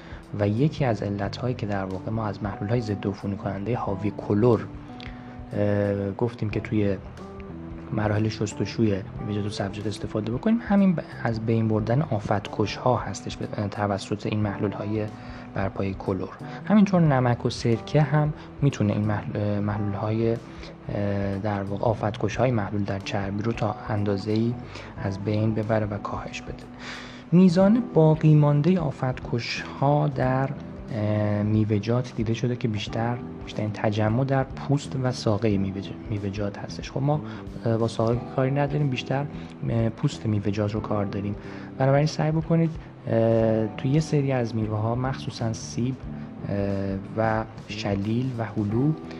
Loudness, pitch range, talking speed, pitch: -25 LUFS, 105-125 Hz, 140 wpm, 110 Hz